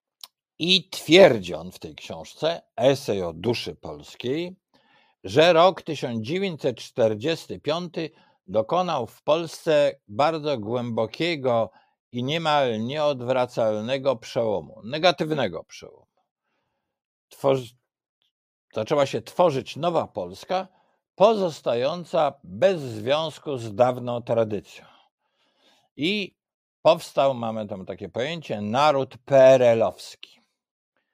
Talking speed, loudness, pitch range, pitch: 85 wpm, -23 LUFS, 115-165 Hz, 135 Hz